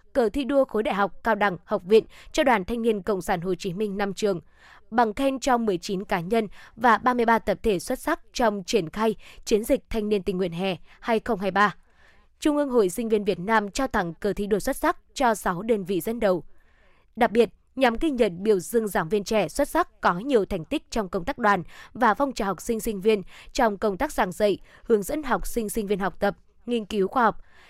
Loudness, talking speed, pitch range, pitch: -25 LUFS, 235 wpm, 200-235 Hz, 220 Hz